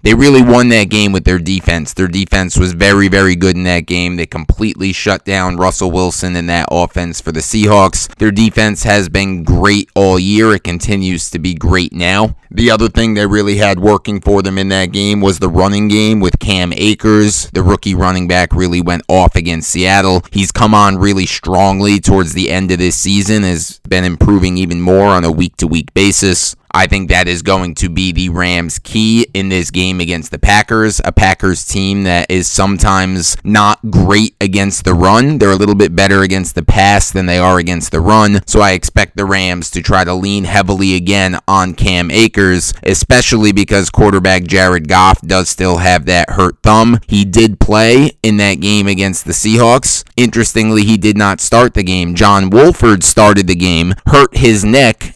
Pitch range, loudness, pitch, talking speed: 90-105 Hz, -10 LUFS, 95 Hz, 200 wpm